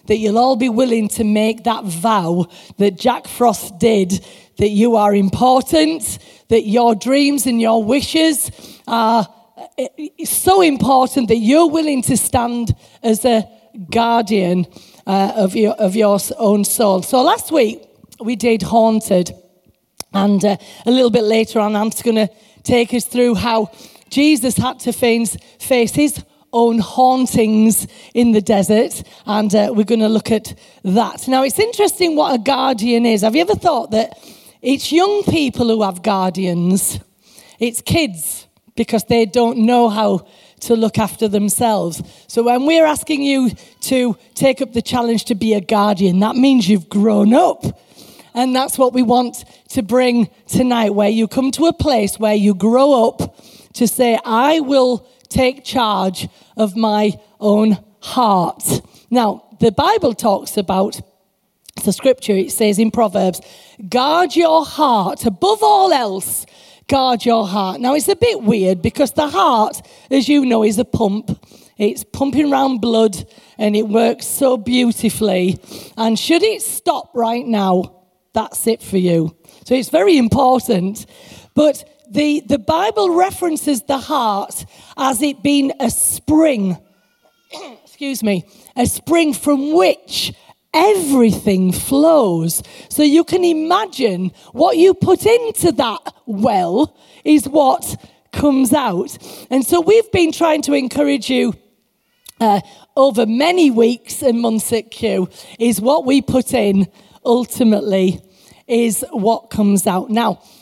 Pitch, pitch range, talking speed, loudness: 235 Hz, 210-275 Hz, 150 wpm, -15 LUFS